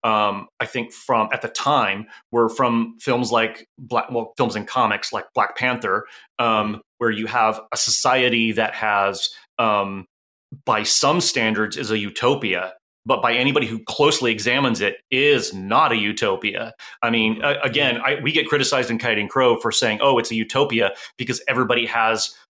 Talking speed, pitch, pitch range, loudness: 175 wpm, 115 Hz, 110-125 Hz, -20 LUFS